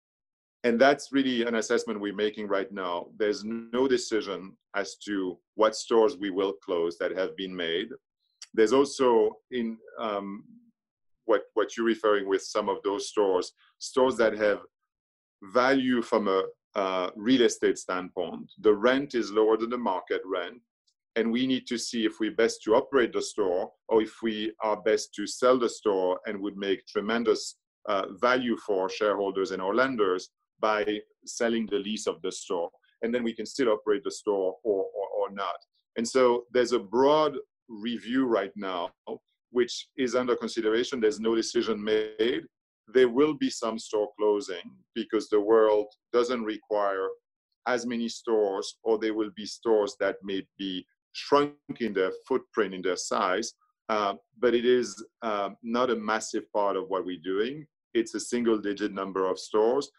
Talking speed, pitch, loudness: 170 wpm, 120 Hz, -28 LUFS